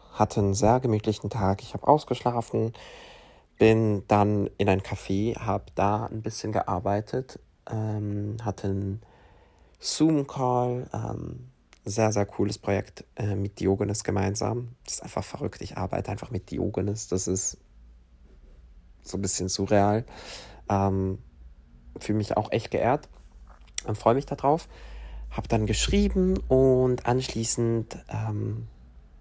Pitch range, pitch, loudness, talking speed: 95-115 Hz, 105 Hz, -27 LUFS, 125 wpm